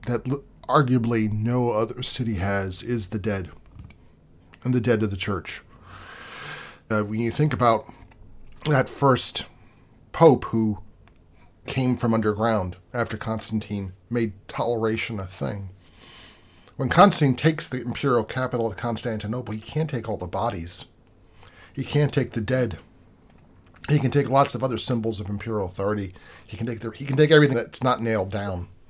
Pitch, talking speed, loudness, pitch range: 115 Hz, 155 wpm, -24 LUFS, 100-125 Hz